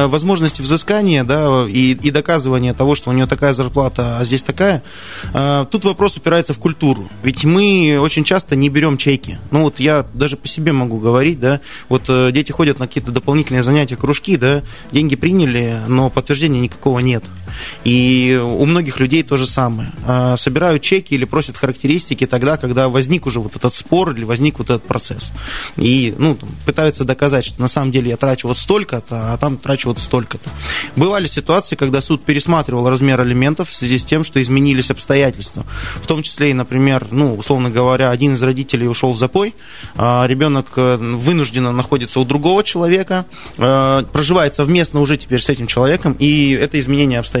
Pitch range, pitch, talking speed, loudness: 125-150 Hz, 135 Hz, 175 wpm, -15 LUFS